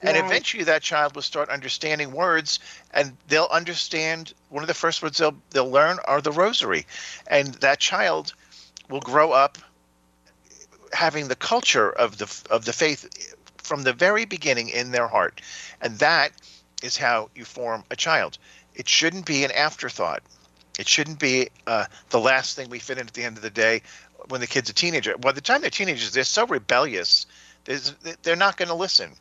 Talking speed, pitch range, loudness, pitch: 185 wpm, 120-165 Hz, -22 LUFS, 145 Hz